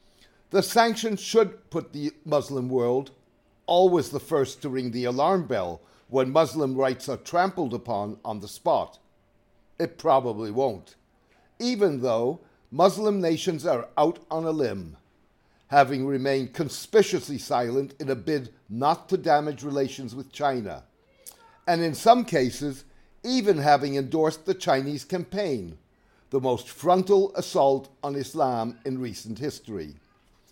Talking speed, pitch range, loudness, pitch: 135 wpm, 125-175 Hz, -25 LUFS, 140 Hz